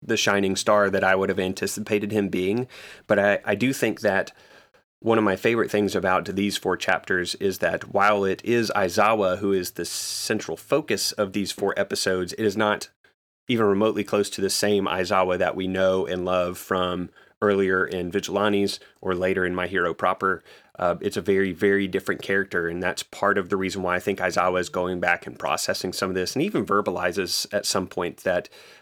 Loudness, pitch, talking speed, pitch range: -24 LUFS, 95 Hz, 200 wpm, 90-100 Hz